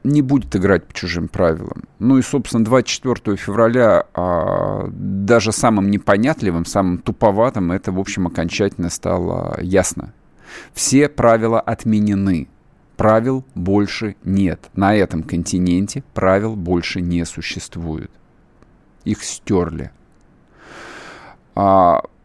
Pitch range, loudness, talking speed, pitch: 90-115 Hz, -17 LUFS, 105 wpm, 100 Hz